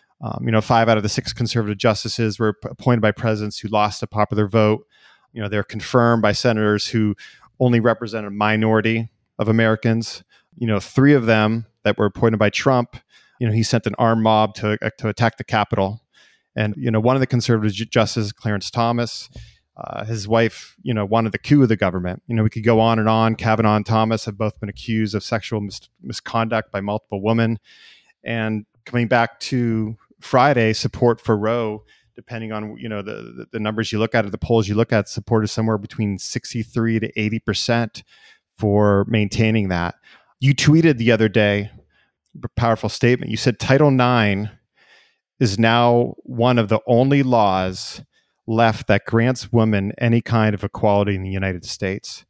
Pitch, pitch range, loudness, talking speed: 110 Hz, 105-115 Hz, -19 LUFS, 190 wpm